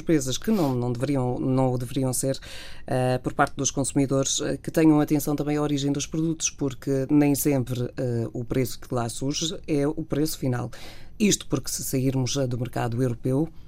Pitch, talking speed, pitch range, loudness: 135 Hz, 190 wpm, 130-150 Hz, -25 LUFS